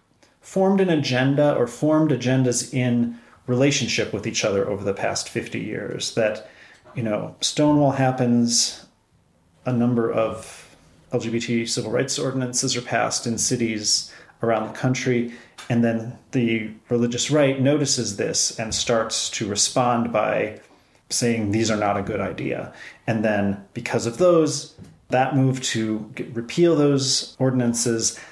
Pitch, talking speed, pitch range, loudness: 120 Hz, 140 wpm, 115-130 Hz, -22 LUFS